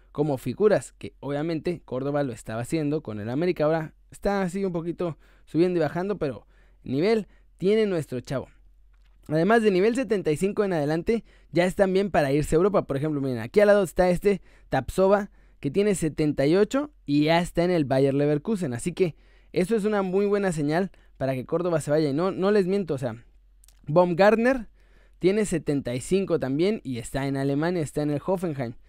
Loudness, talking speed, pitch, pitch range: -25 LUFS, 185 wpm, 165 Hz, 140-195 Hz